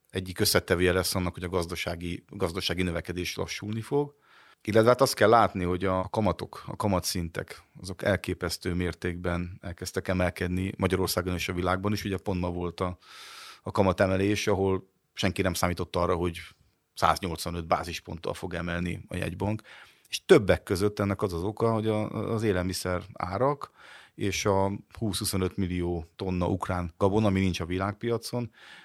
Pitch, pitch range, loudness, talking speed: 95 Hz, 90-105 Hz, -28 LUFS, 150 wpm